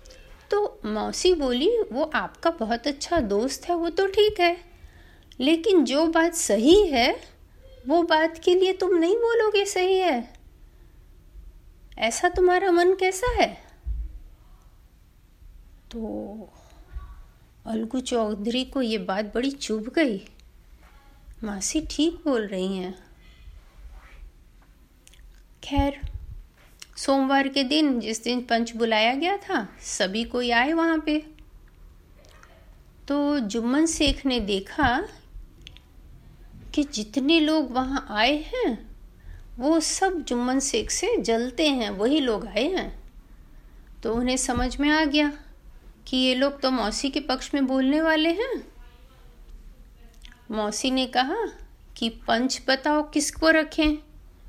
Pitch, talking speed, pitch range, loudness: 260 Hz, 120 wpm, 210-320 Hz, -24 LUFS